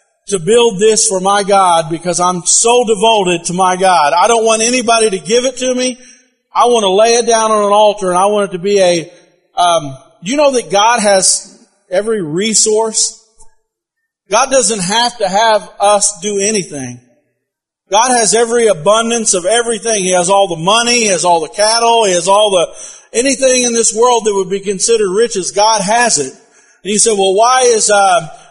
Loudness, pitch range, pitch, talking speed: -11 LUFS, 195-235 Hz, 215 Hz, 200 wpm